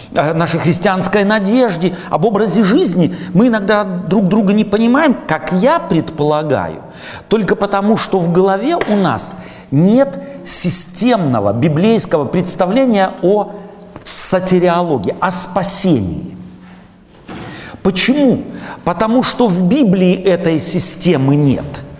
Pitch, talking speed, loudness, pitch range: 185 Hz, 105 wpm, -13 LUFS, 170-210 Hz